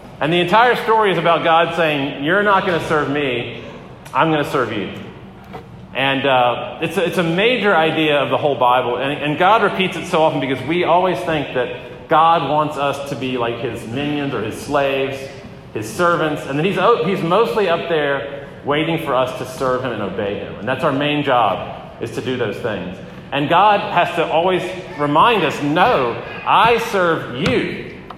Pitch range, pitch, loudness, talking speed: 135-175 Hz, 155 Hz, -17 LUFS, 200 wpm